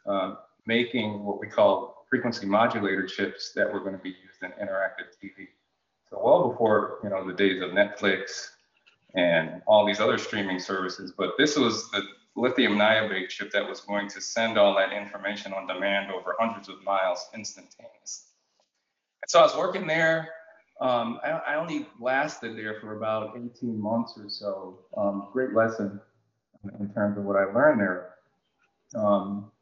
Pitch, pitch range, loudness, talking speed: 100 Hz, 100-115 Hz, -26 LUFS, 170 wpm